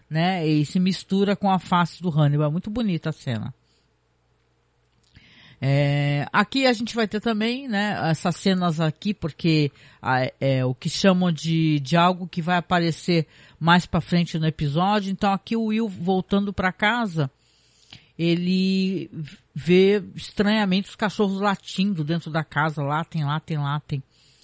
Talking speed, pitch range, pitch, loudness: 145 wpm, 150-195 Hz, 170 Hz, -23 LUFS